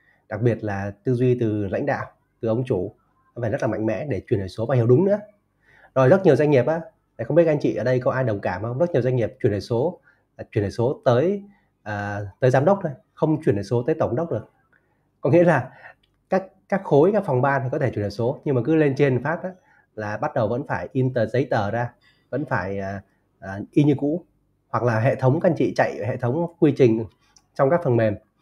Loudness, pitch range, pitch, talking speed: -22 LUFS, 110-150 Hz, 130 Hz, 255 wpm